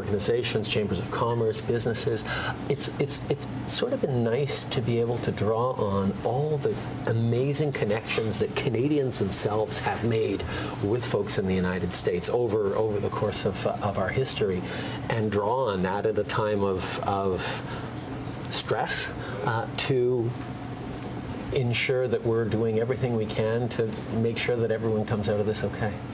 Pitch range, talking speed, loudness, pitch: 105-125 Hz, 165 wpm, -27 LUFS, 115 Hz